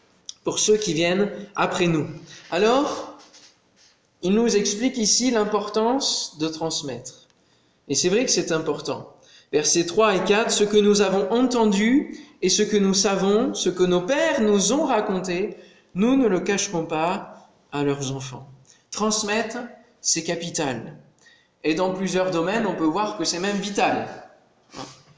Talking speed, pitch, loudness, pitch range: 150 wpm, 200 Hz, -22 LUFS, 170-220 Hz